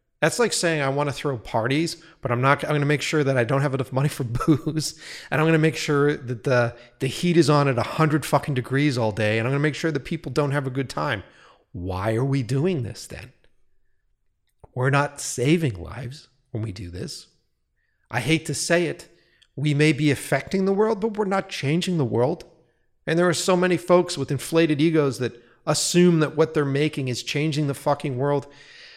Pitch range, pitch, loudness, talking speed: 130-160 Hz, 145 Hz, -23 LUFS, 220 wpm